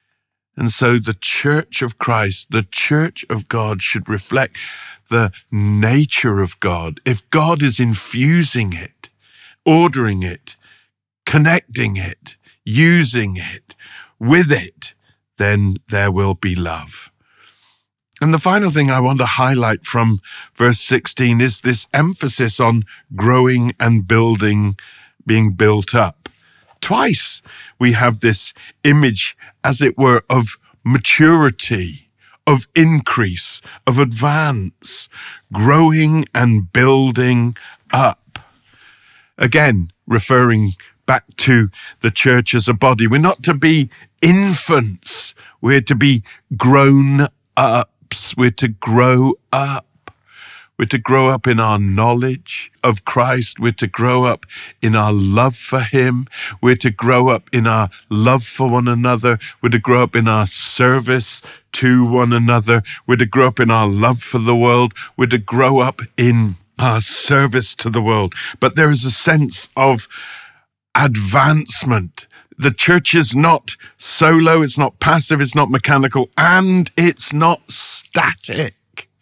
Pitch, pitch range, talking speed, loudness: 125 Hz, 110-140 Hz, 135 wpm, -14 LUFS